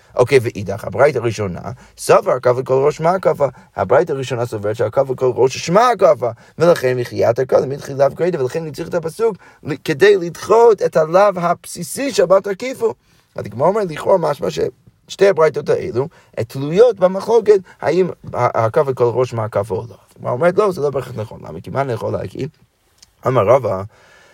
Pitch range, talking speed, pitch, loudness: 125-195 Hz, 170 wpm, 155 Hz, -16 LUFS